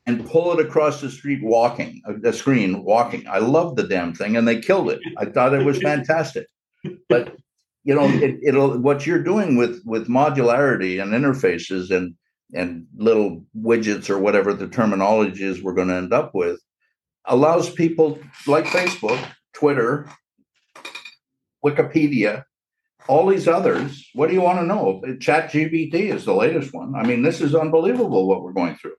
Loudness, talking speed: -20 LUFS, 170 wpm